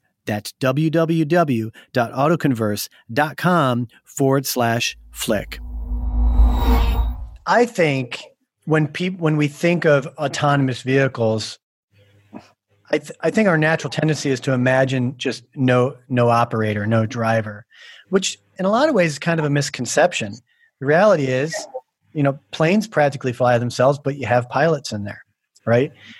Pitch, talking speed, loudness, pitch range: 135 Hz, 135 wpm, -19 LUFS, 115-155 Hz